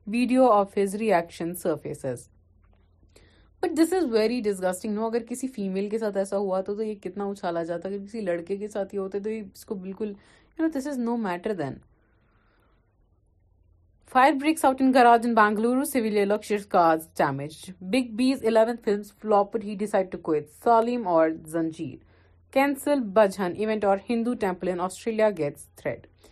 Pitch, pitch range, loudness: 200 Hz, 160-225 Hz, -25 LUFS